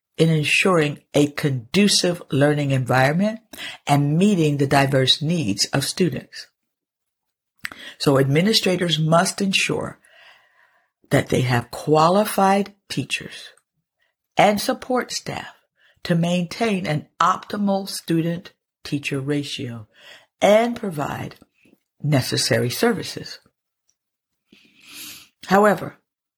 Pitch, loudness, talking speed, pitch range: 160 Hz, -20 LUFS, 85 wpm, 145-195 Hz